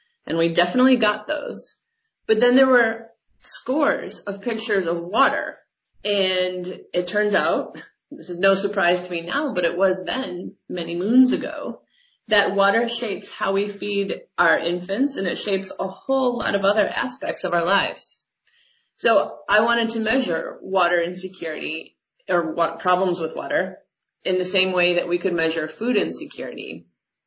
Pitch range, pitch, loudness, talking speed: 180-230 Hz, 195 Hz, -22 LUFS, 160 wpm